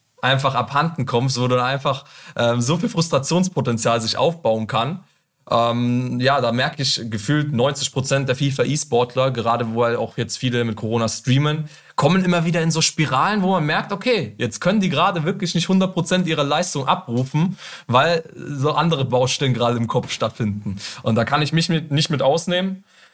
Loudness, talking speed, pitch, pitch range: -20 LUFS, 170 wpm, 140 Hz, 120-170 Hz